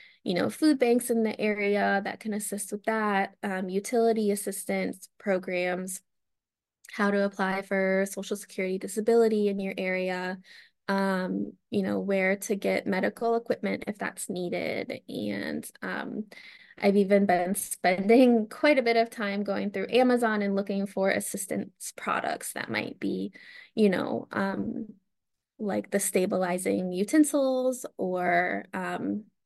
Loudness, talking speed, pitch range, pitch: -28 LUFS, 140 wpm, 190-225 Hz, 200 Hz